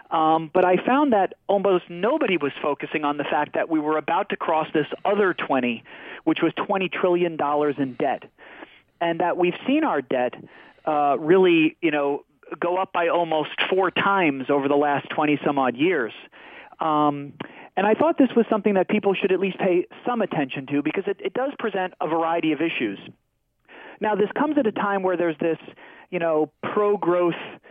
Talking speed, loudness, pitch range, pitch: 190 wpm, -23 LUFS, 155-200 Hz, 175 Hz